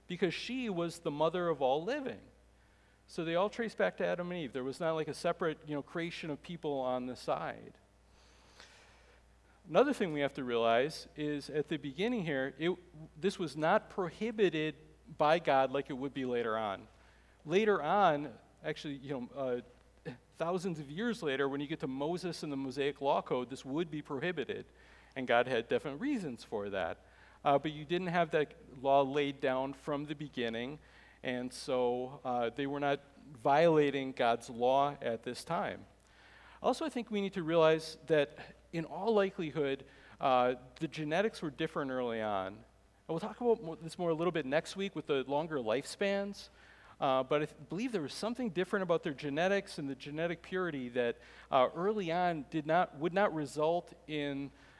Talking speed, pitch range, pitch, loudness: 185 wpm, 135-175 Hz, 155 Hz, -35 LUFS